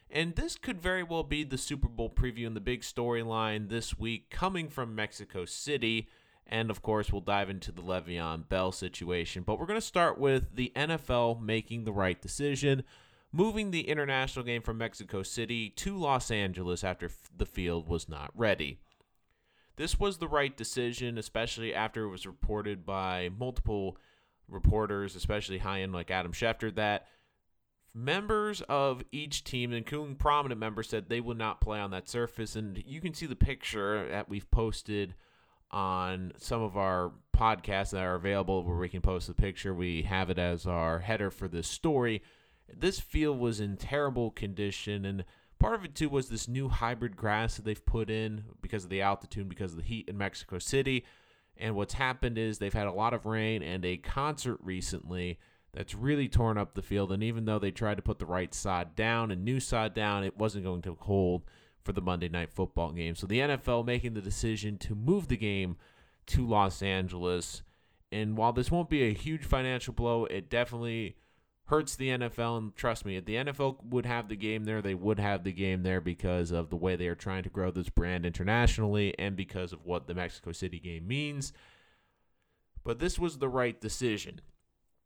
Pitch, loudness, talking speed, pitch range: 105 Hz, -33 LUFS, 195 wpm, 95-120 Hz